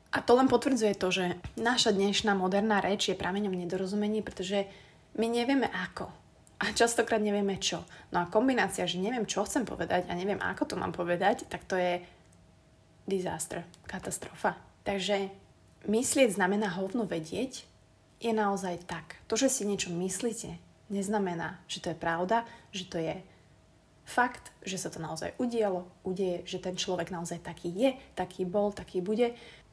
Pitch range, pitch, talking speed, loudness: 180-225 Hz, 200 Hz, 155 wpm, -31 LUFS